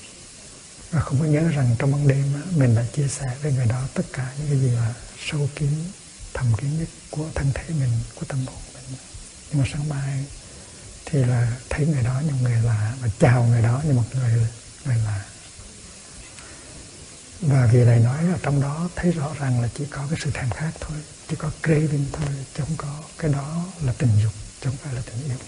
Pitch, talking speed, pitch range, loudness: 135 Hz, 215 wpm, 120-150 Hz, -23 LUFS